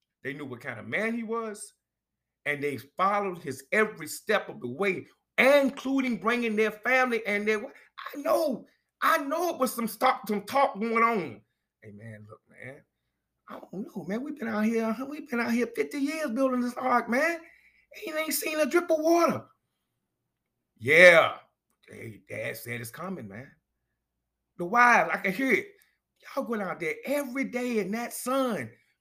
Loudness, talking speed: -26 LUFS, 180 wpm